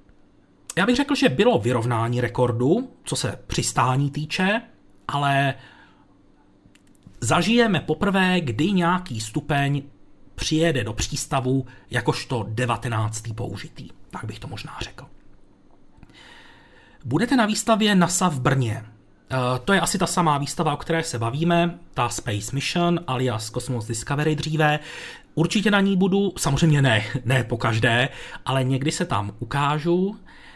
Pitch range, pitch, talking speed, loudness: 120-170 Hz, 140 Hz, 130 wpm, -22 LUFS